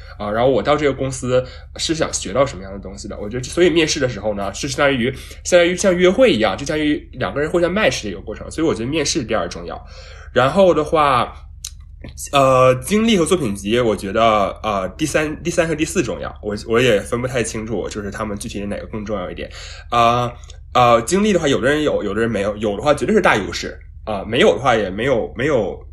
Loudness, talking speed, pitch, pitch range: -18 LUFS, 365 characters per minute, 120 Hz, 100-155 Hz